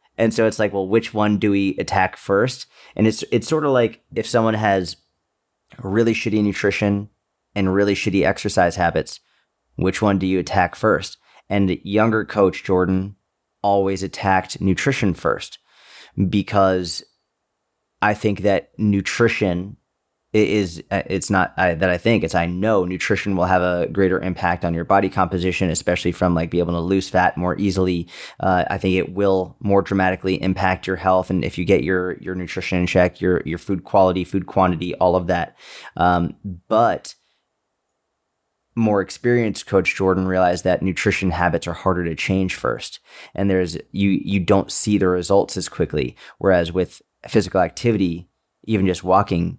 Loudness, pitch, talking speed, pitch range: -20 LUFS, 95 Hz, 165 wpm, 90-100 Hz